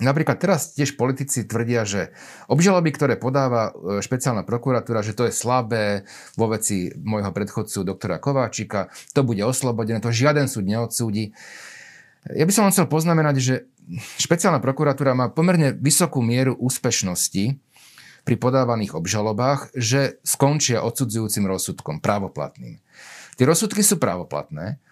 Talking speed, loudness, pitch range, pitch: 130 wpm, -21 LUFS, 110-140 Hz, 125 Hz